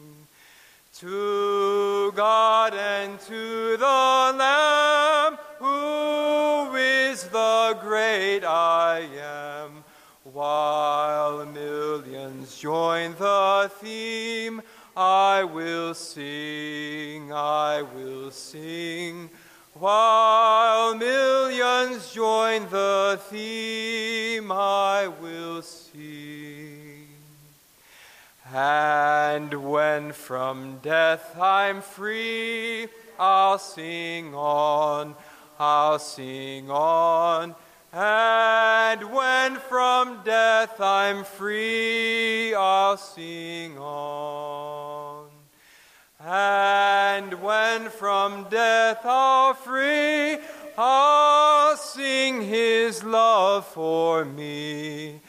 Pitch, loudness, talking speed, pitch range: 195 Hz, -22 LUFS, 70 wpm, 150-225 Hz